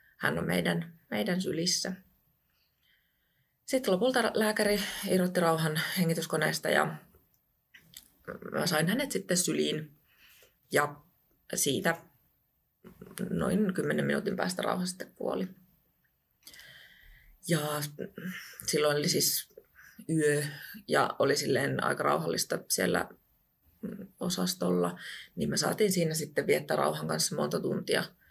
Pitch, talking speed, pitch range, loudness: 180 Hz, 100 wpm, 155-200 Hz, -30 LUFS